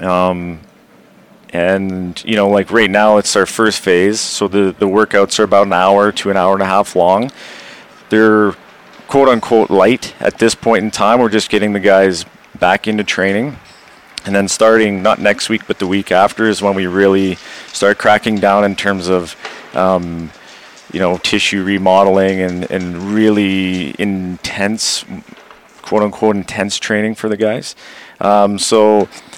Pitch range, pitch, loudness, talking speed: 95-105 Hz, 100 Hz, -13 LUFS, 165 wpm